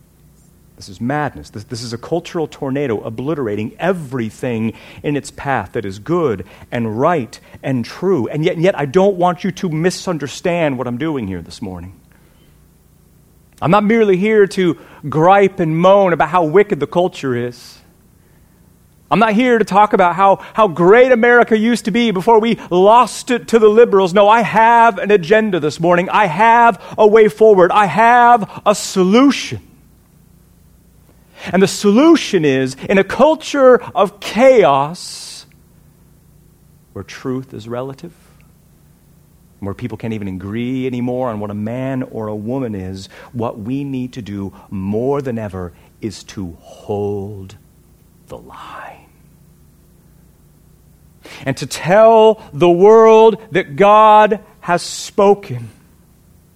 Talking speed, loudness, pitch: 145 wpm, -13 LUFS, 170 Hz